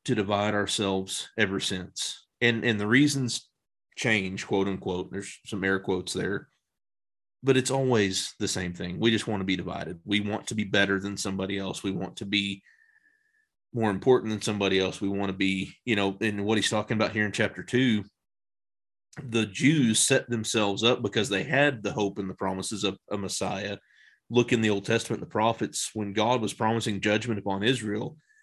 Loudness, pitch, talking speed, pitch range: -27 LUFS, 105 Hz, 190 wpm, 100-120 Hz